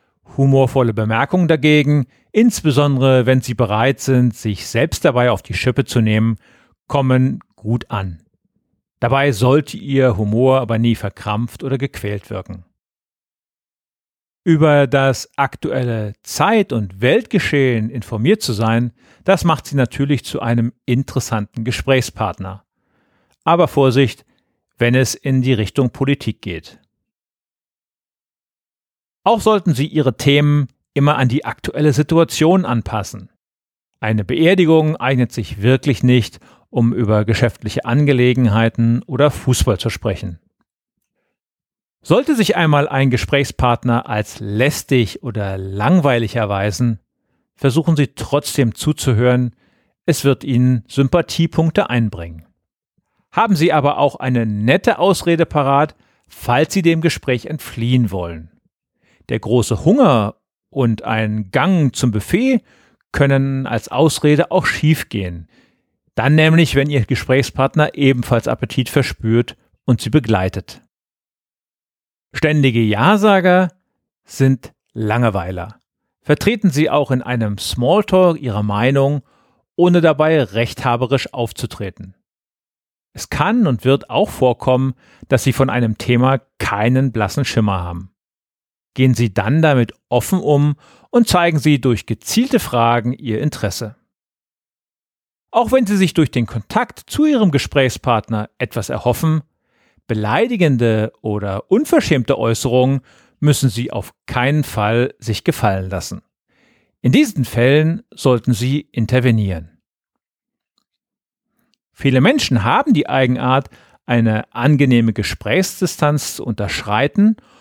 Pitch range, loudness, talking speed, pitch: 115-145 Hz, -16 LUFS, 115 wpm, 130 Hz